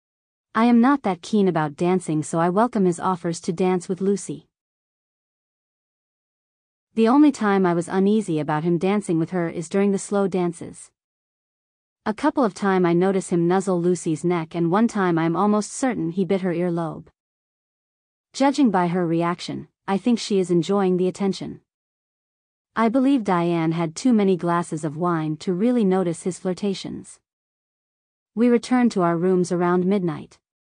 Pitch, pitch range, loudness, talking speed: 185 Hz, 170-205 Hz, -21 LUFS, 165 wpm